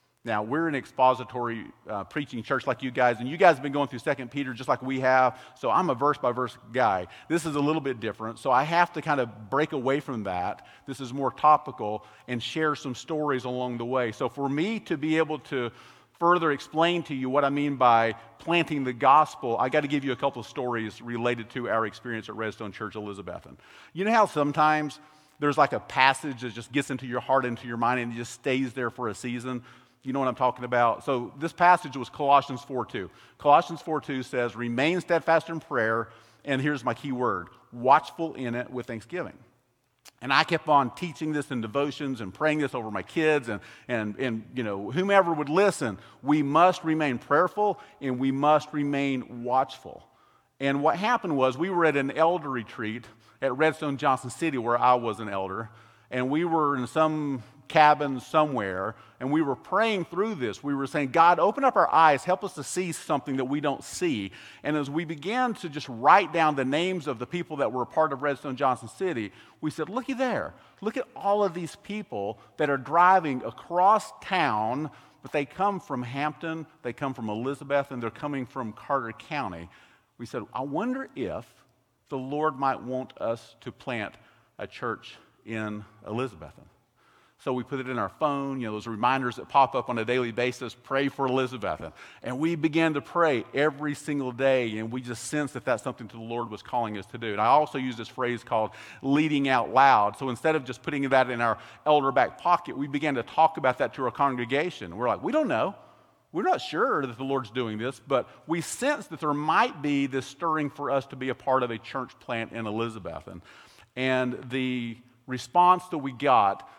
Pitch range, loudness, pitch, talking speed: 120-155 Hz, -27 LUFS, 135 Hz, 210 wpm